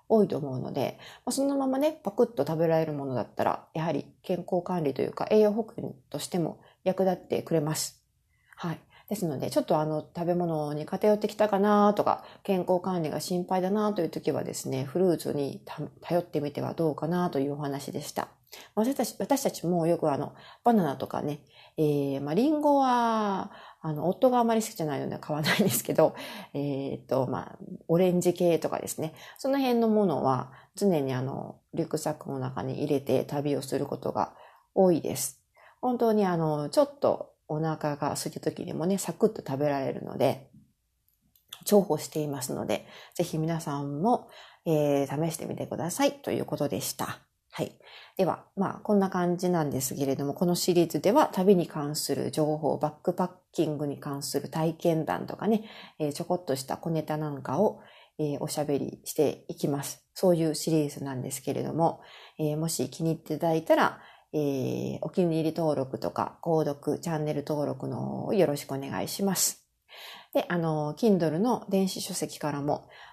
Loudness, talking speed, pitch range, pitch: -29 LUFS, 360 characters per minute, 150-195 Hz, 160 Hz